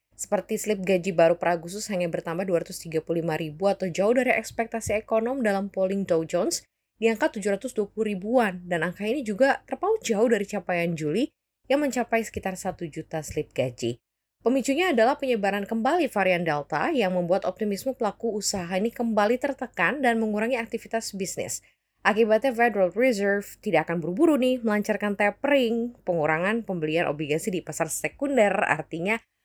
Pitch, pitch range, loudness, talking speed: 205 Hz, 175-230 Hz, -25 LUFS, 145 wpm